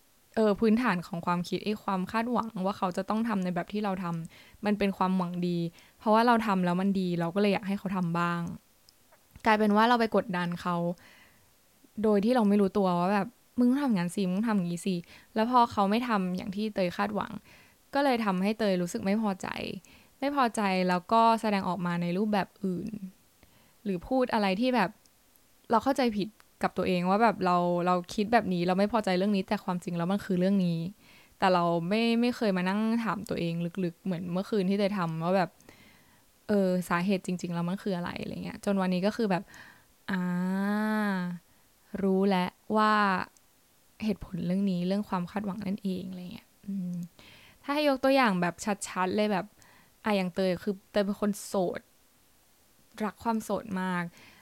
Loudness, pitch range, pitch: -29 LUFS, 180-215 Hz, 195 Hz